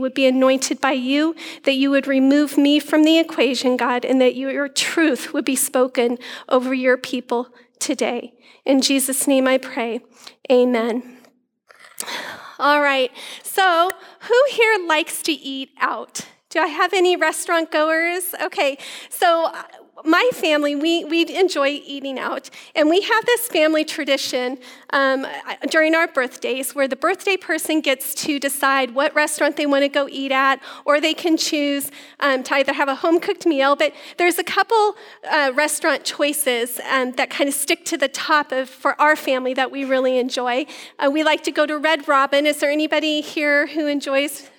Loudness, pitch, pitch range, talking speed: -19 LUFS, 285 Hz, 265-320 Hz, 175 wpm